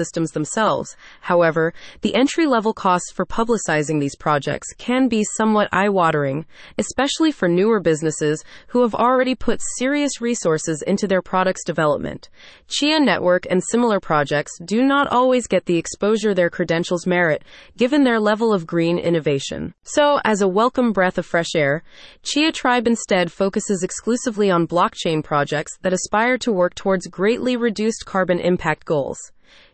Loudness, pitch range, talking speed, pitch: -19 LUFS, 170-235 Hz, 155 wpm, 190 Hz